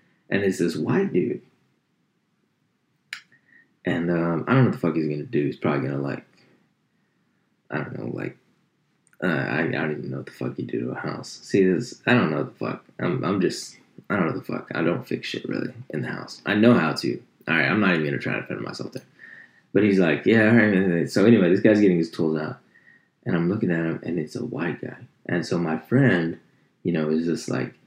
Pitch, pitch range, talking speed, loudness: 85 Hz, 80-95 Hz, 240 wpm, -23 LUFS